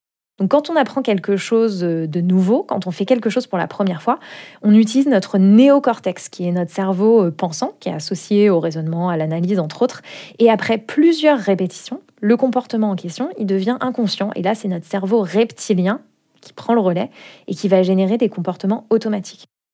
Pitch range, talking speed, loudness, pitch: 185-235 Hz, 190 wpm, -17 LUFS, 205 Hz